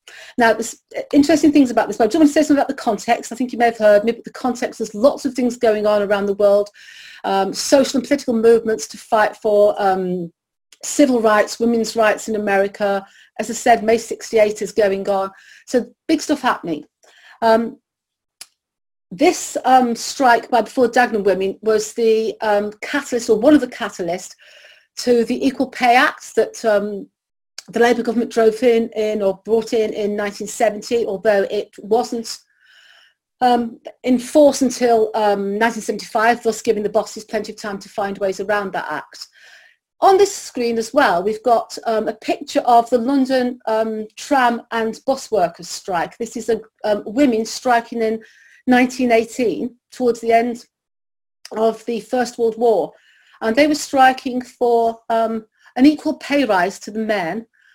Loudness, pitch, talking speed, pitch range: -18 LUFS, 230 Hz, 170 wpm, 215-250 Hz